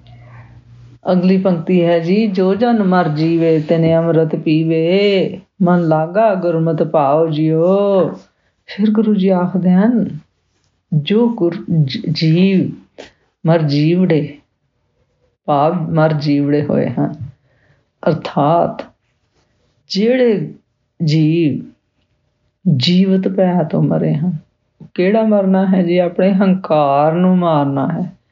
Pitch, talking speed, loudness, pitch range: 170 Hz, 95 wpm, -14 LUFS, 155-190 Hz